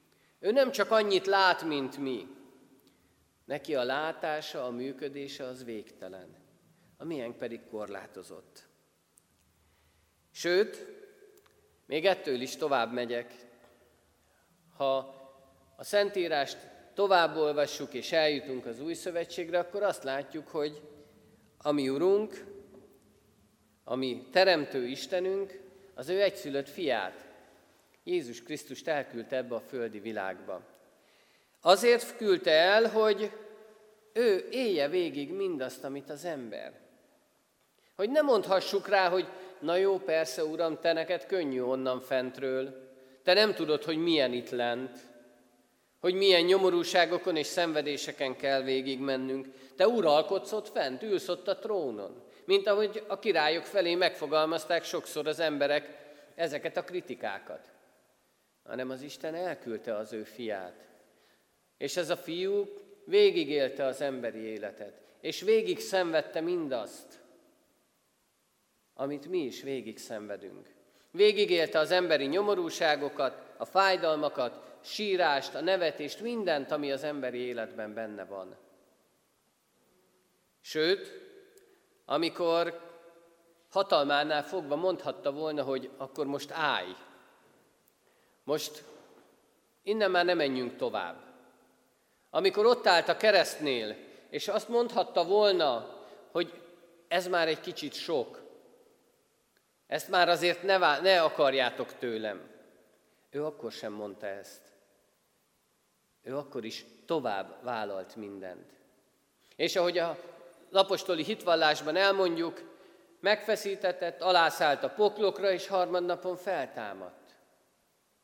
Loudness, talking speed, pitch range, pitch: -30 LUFS, 110 wpm, 135-195 Hz, 165 Hz